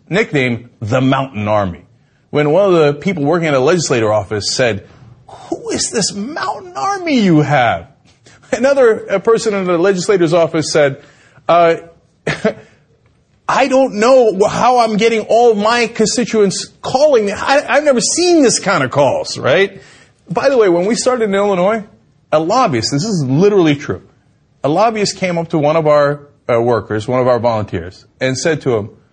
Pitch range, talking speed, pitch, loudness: 130-220 Hz, 165 wpm, 170 Hz, -13 LUFS